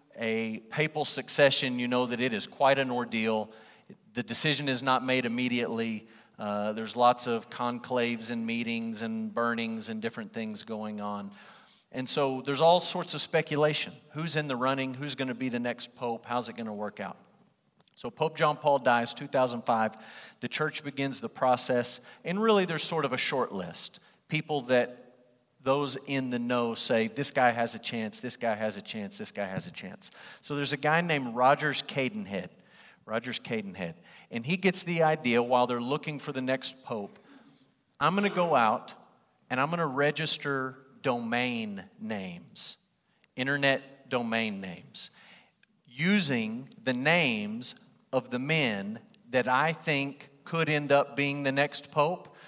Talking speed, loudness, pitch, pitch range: 165 wpm, -29 LUFS, 130 Hz, 120-155 Hz